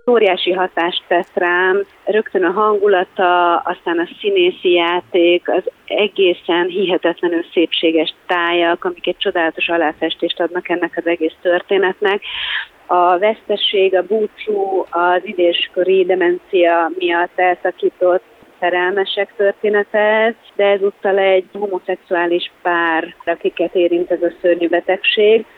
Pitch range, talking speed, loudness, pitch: 175-200 Hz, 110 wpm, -16 LUFS, 180 Hz